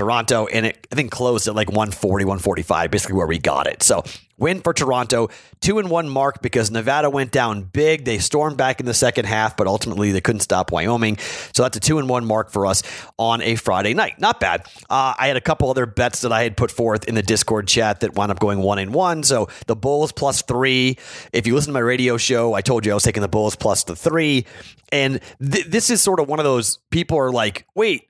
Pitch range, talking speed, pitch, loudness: 105-135 Hz, 245 wpm, 120 Hz, -19 LUFS